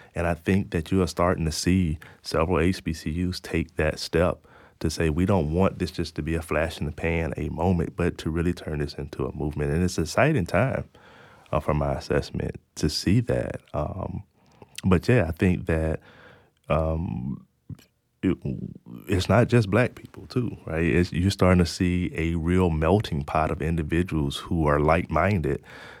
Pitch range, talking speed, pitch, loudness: 80-90 Hz, 180 wpm, 85 Hz, -25 LUFS